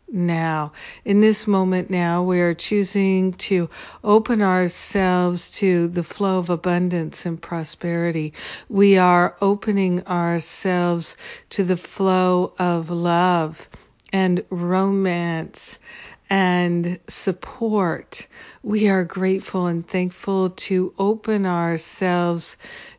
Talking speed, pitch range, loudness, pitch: 100 wpm, 175-195 Hz, -21 LUFS, 180 Hz